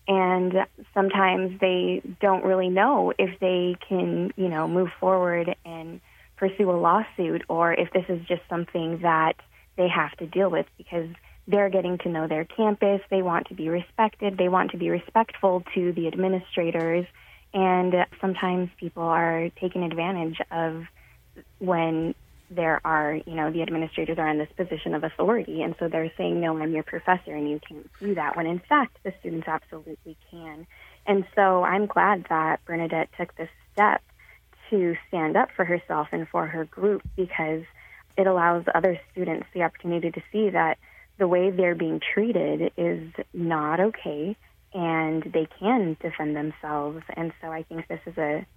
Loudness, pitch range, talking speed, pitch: -25 LUFS, 160-185 Hz, 170 wpm, 175 Hz